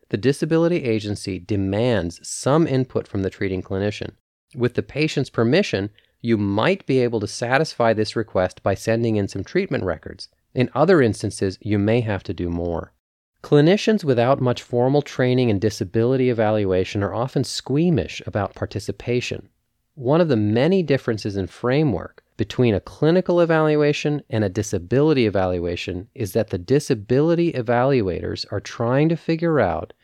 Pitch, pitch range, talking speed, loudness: 120 Hz, 100-140 Hz, 150 wpm, -21 LUFS